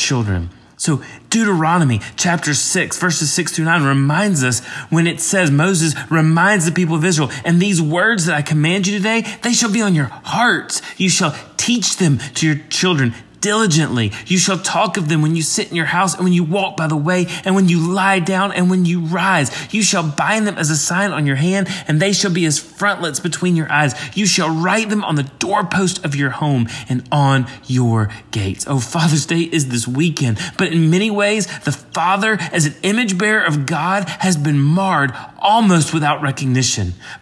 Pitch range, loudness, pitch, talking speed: 145-190 Hz, -16 LUFS, 165 Hz, 205 wpm